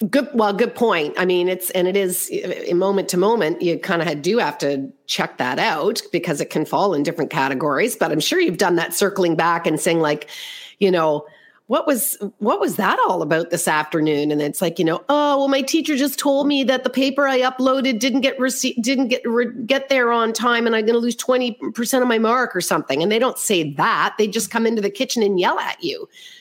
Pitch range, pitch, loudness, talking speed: 185-270 Hz, 235 Hz, -19 LUFS, 235 wpm